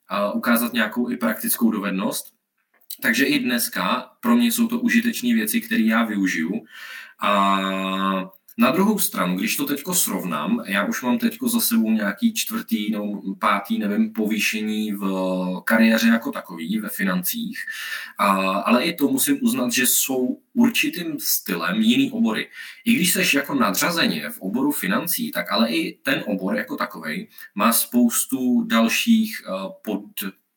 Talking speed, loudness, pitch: 145 wpm, -21 LUFS, 220 Hz